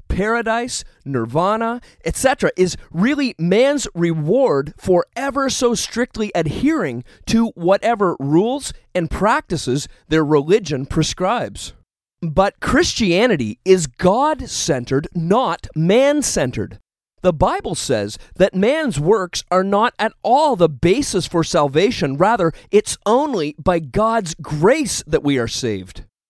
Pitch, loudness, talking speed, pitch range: 180 Hz, -18 LUFS, 120 wpm, 150-225 Hz